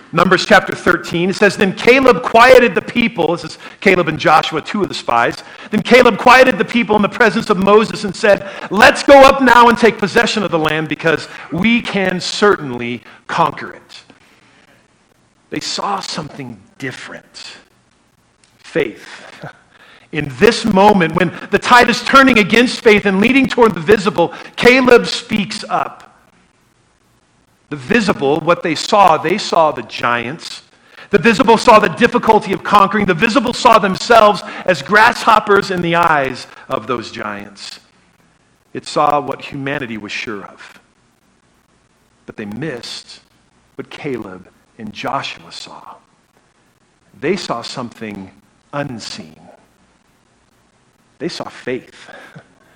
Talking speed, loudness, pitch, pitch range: 135 wpm, -12 LUFS, 205 Hz, 165-230 Hz